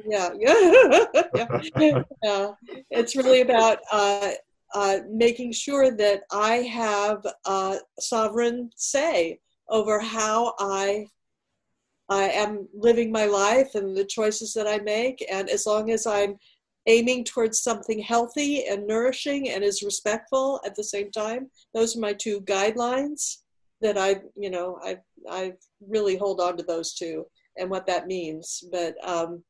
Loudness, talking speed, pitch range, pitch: -24 LUFS, 145 wpm, 200-235 Hz, 215 Hz